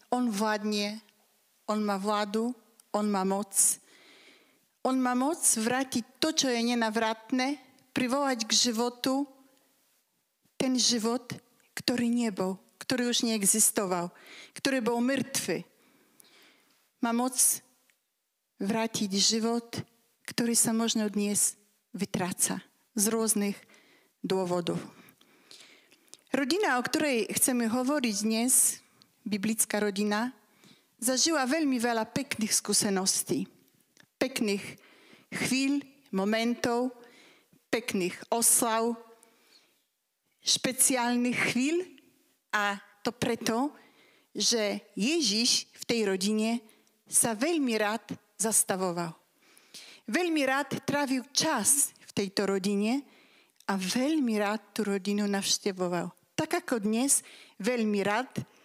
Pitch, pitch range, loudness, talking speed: 230 Hz, 210-260 Hz, -28 LUFS, 95 wpm